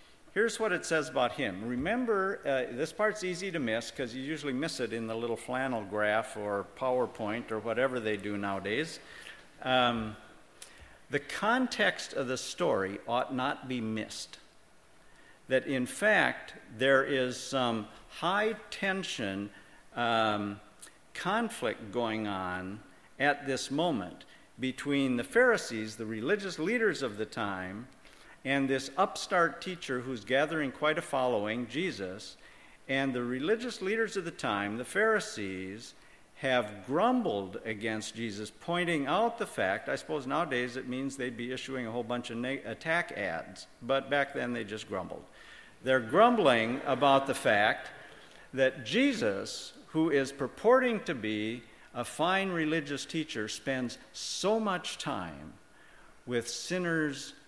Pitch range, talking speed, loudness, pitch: 115-170 Hz, 140 wpm, -31 LUFS, 130 Hz